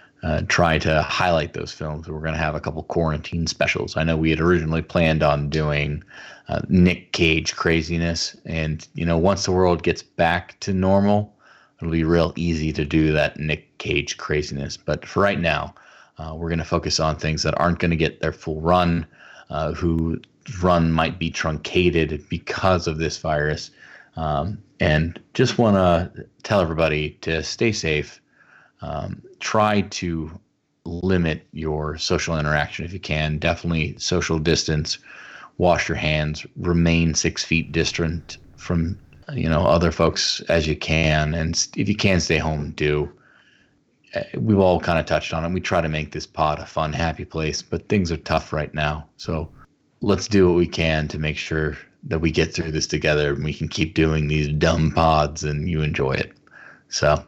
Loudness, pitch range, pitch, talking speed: -22 LUFS, 75-85 Hz, 80 Hz, 180 wpm